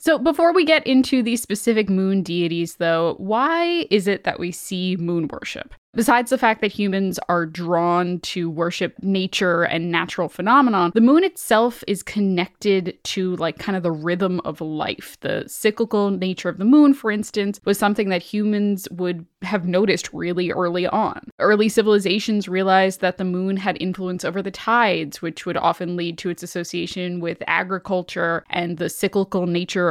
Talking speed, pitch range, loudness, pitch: 175 wpm, 175-210 Hz, -20 LUFS, 190 Hz